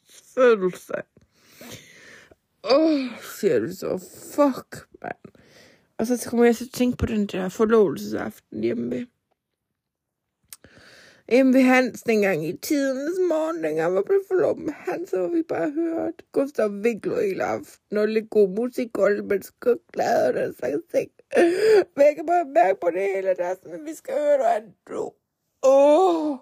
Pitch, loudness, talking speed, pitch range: 255 Hz, -22 LUFS, 165 wpm, 200-330 Hz